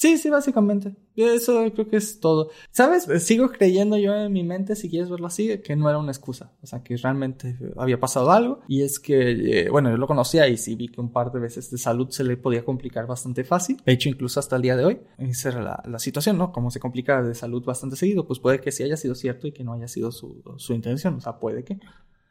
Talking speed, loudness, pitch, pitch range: 255 wpm, -23 LUFS, 135 Hz, 125-195 Hz